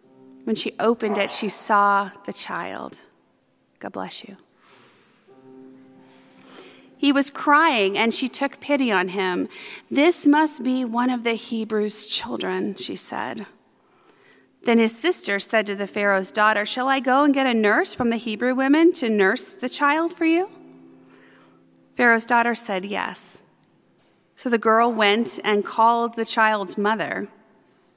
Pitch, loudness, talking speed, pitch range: 220 Hz, -20 LUFS, 145 wpm, 200-255 Hz